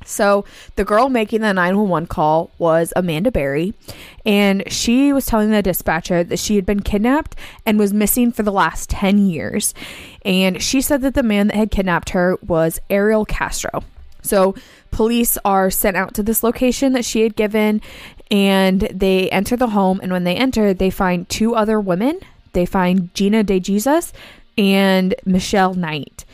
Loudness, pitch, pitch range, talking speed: -17 LUFS, 200 Hz, 185-220 Hz, 175 wpm